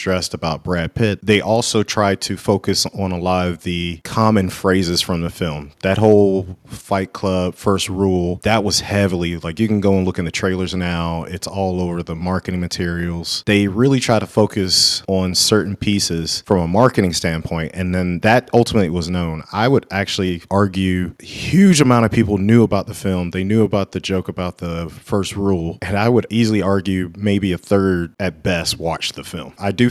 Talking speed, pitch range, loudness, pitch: 195 wpm, 90-105 Hz, -18 LUFS, 95 Hz